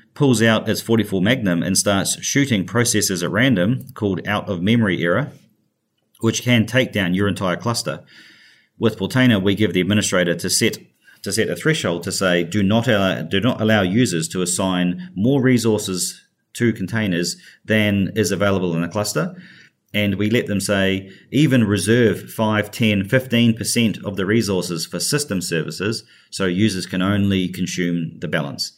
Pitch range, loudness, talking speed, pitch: 95-115 Hz, -19 LUFS, 165 wpm, 105 Hz